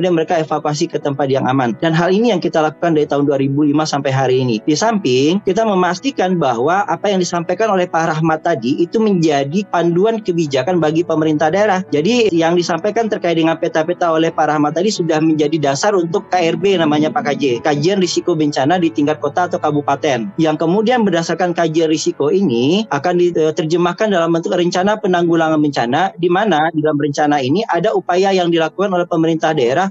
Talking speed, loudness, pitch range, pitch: 180 wpm, -15 LUFS, 155-180 Hz, 170 Hz